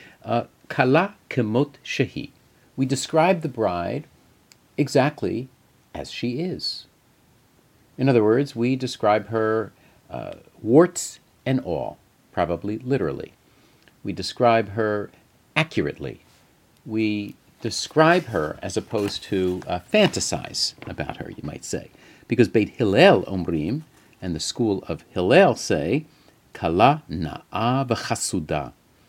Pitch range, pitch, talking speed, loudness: 100-135 Hz, 115 Hz, 105 wpm, -23 LUFS